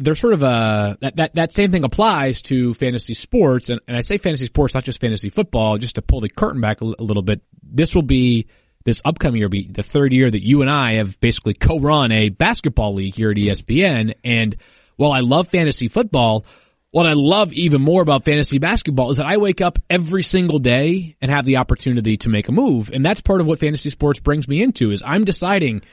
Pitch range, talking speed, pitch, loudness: 115-160 Hz, 235 wpm, 135 Hz, -17 LUFS